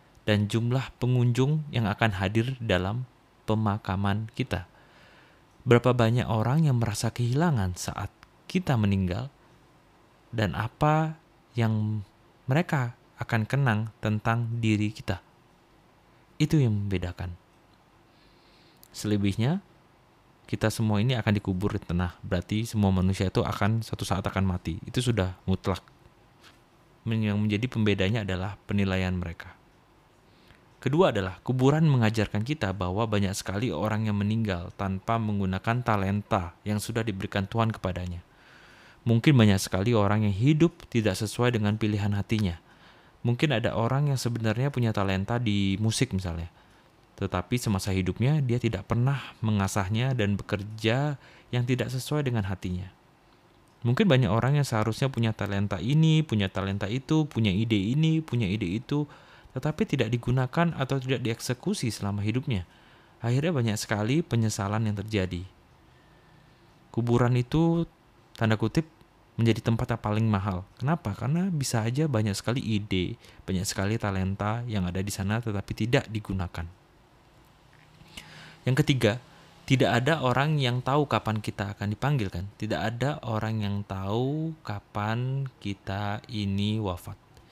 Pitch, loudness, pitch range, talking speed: 110 Hz, -27 LUFS, 100-125 Hz, 130 wpm